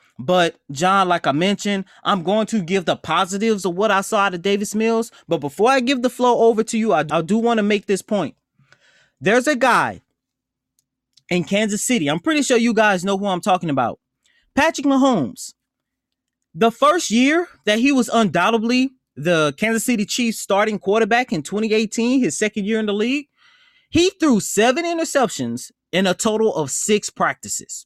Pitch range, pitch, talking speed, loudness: 190-245 Hz, 215 Hz, 185 wpm, -19 LUFS